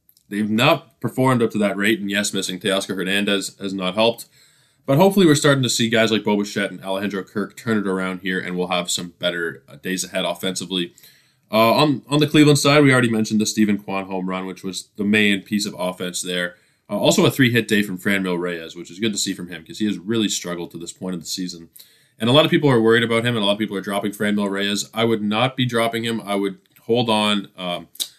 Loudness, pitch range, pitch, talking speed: -20 LUFS, 95-115 Hz, 105 Hz, 250 wpm